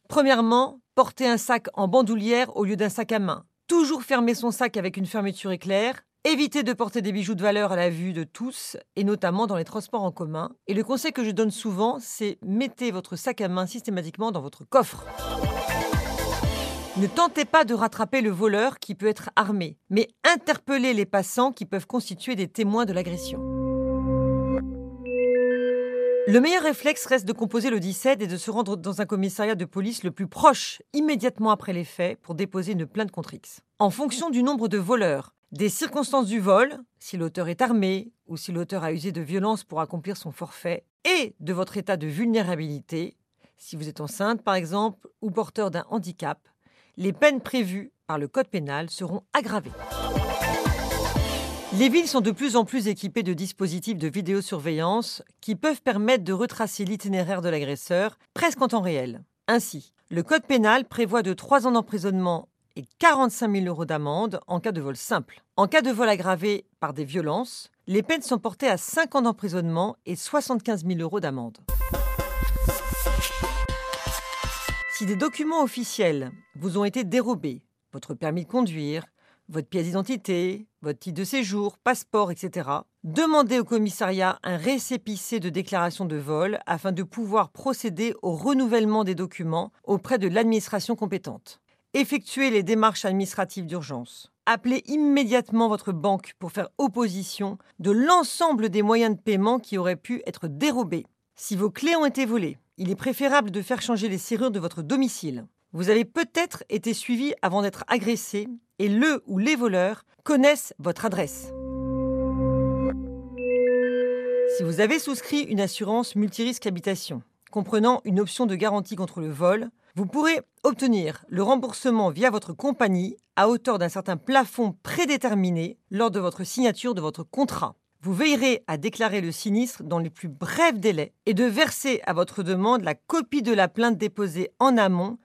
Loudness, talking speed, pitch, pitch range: -25 LUFS, 170 wpm, 210 Hz, 180-245 Hz